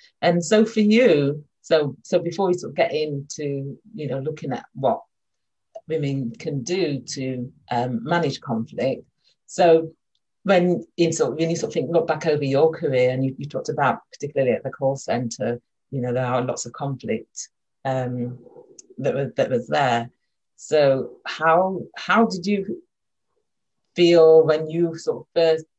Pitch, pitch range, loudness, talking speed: 155 Hz, 130-175 Hz, -22 LUFS, 170 wpm